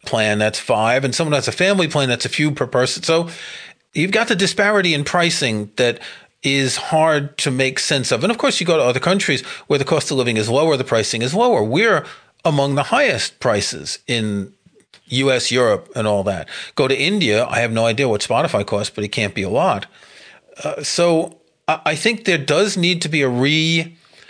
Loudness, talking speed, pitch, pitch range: -17 LUFS, 210 wpm, 145 Hz, 125-170 Hz